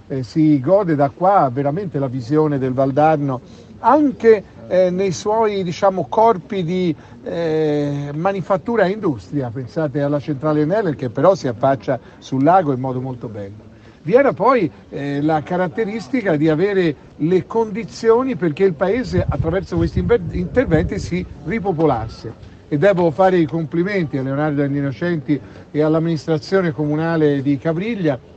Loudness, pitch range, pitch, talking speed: -18 LUFS, 140-190 Hz, 155 Hz, 140 wpm